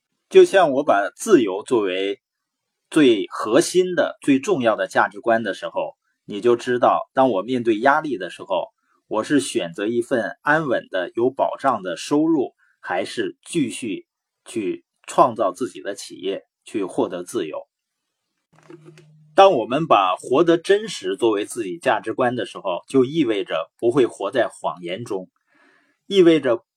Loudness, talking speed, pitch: -20 LUFS, 220 characters per minute, 320 Hz